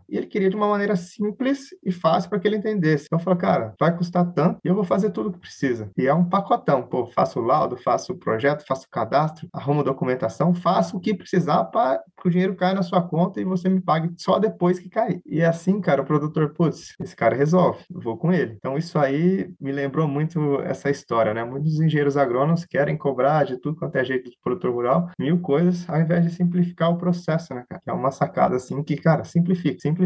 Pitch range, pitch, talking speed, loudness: 145-185 Hz, 170 Hz, 240 wpm, -22 LUFS